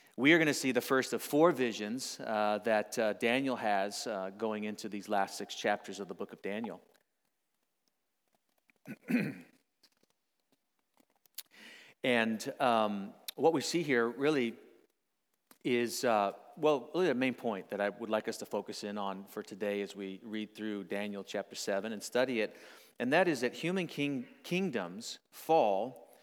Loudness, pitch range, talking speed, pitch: -33 LUFS, 105-130 Hz, 160 wpm, 115 Hz